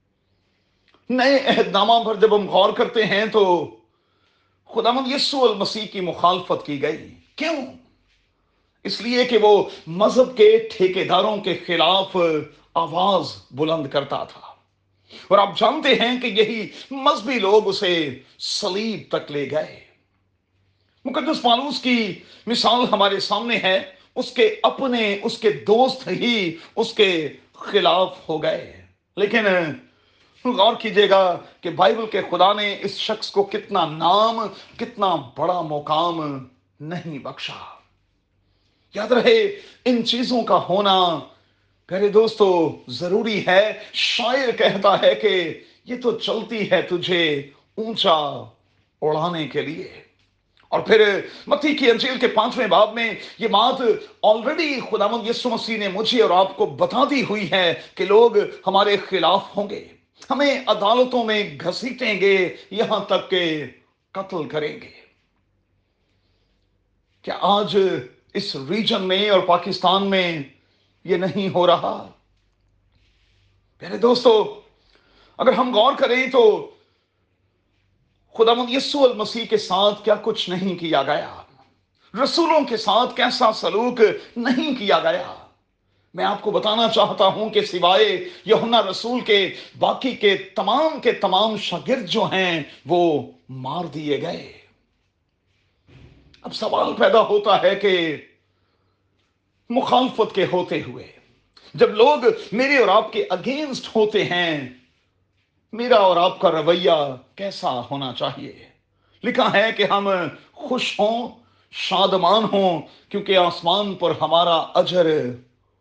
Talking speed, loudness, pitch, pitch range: 125 wpm, -19 LUFS, 195 Hz, 155-230 Hz